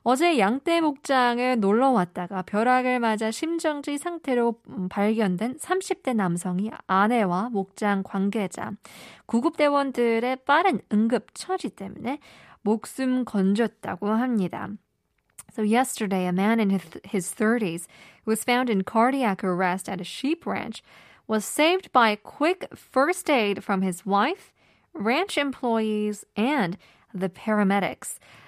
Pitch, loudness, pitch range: 220 Hz, -25 LUFS, 200-260 Hz